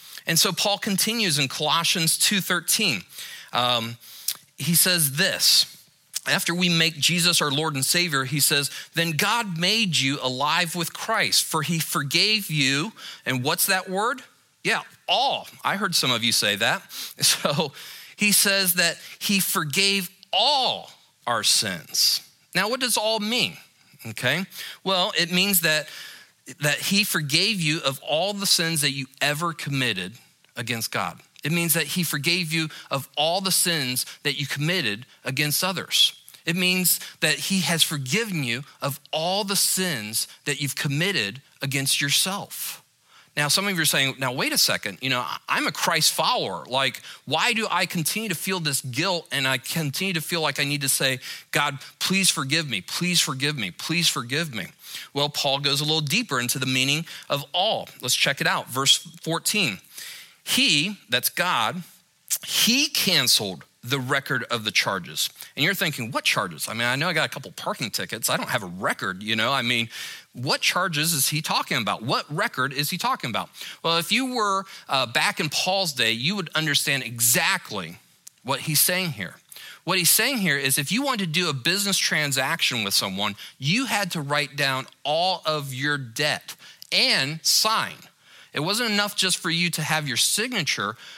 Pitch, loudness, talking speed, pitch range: 160 Hz, -22 LUFS, 180 wpm, 140-185 Hz